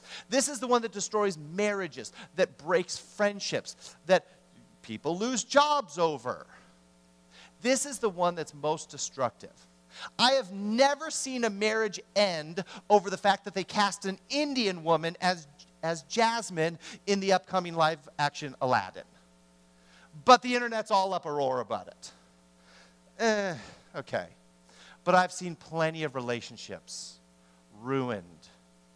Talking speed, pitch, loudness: 135 wpm, 170 Hz, -29 LUFS